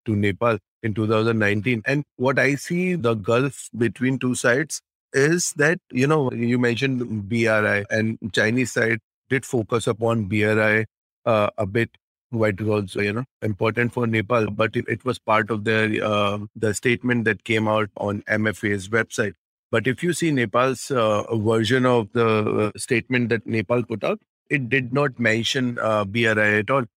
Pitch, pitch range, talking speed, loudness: 115 Hz, 110-125 Hz, 165 wpm, -22 LUFS